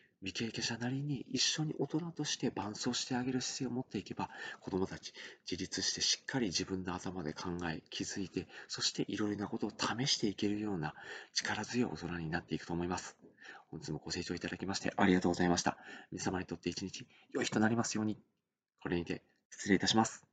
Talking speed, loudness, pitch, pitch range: 430 characters per minute, -36 LUFS, 100 Hz, 90-115 Hz